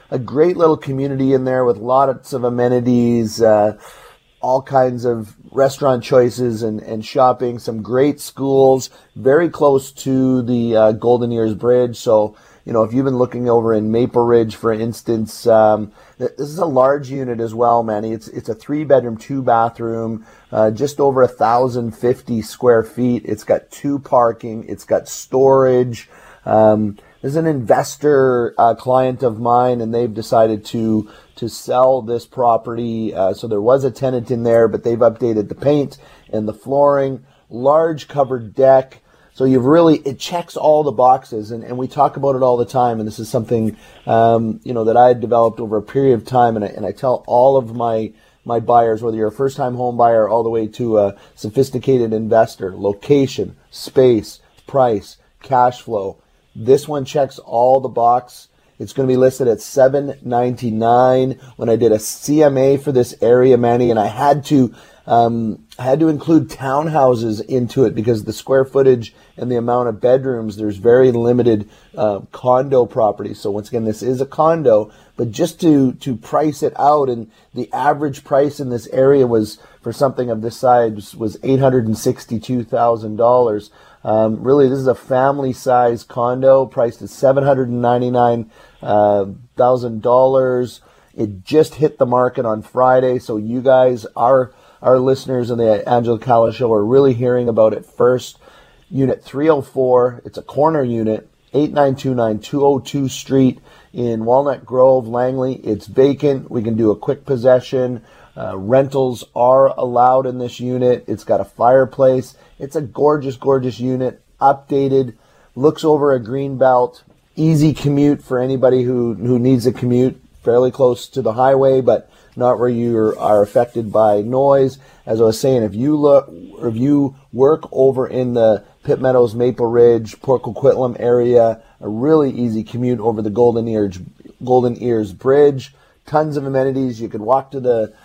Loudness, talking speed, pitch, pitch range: -16 LUFS, 170 wpm, 125 Hz, 115-135 Hz